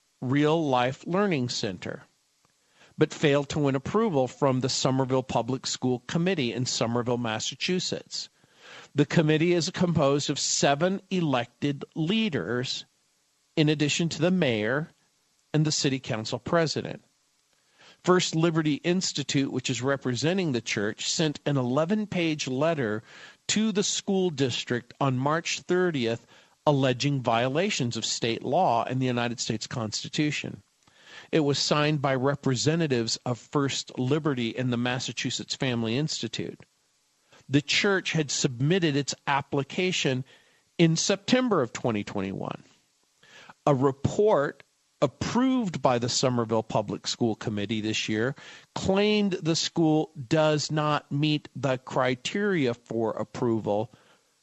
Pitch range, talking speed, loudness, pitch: 125-165 Hz, 120 wpm, -26 LUFS, 140 Hz